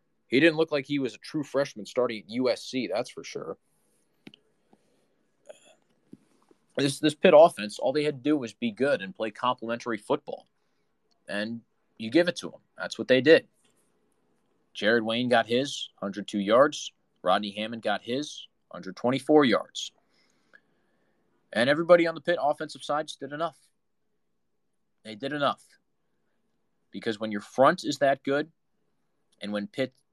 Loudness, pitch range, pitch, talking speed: -26 LUFS, 110-150 Hz, 130 Hz, 150 wpm